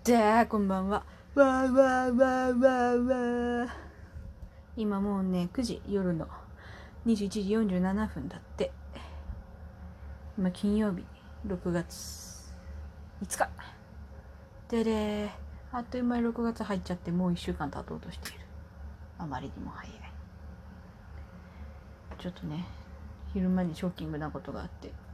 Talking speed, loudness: 195 characters per minute, -31 LUFS